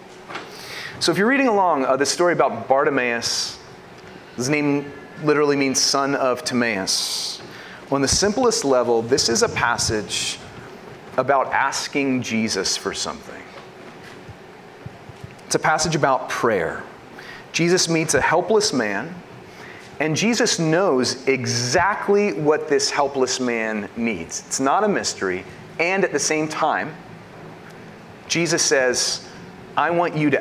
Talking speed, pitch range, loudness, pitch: 130 wpm, 125-170 Hz, -20 LUFS, 145 Hz